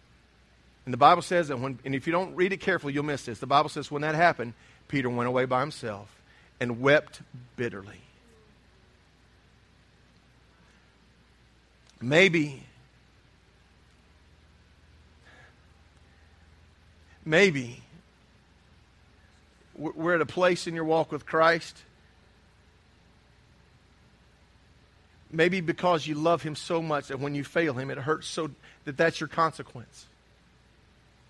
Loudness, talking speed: -27 LUFS, 115 wpm